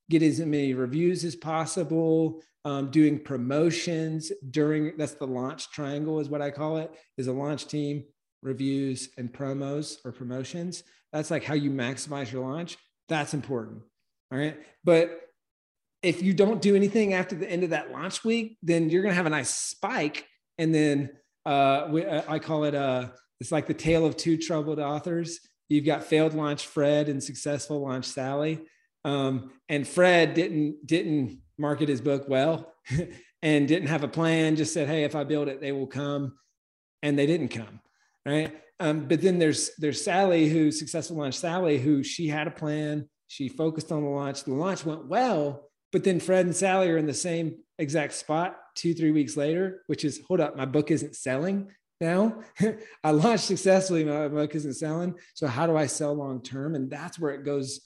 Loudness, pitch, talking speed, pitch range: -27 LUFS, 150 Hz, 185 wpm, 140-165 Hz